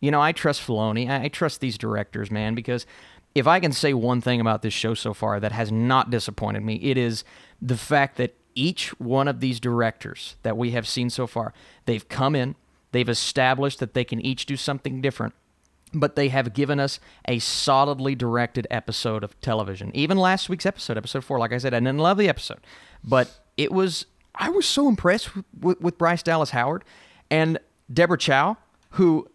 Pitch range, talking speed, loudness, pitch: 115-150 Hz, 195 wpm, -24 LUFS, 130 Hz